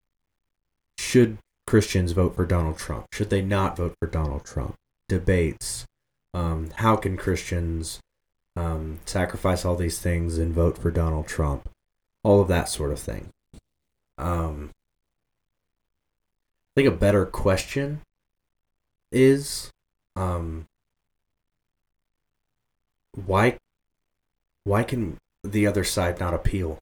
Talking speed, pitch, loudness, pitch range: 110 wpm, 90 Hz, -25 LUFS, 80-100 Hz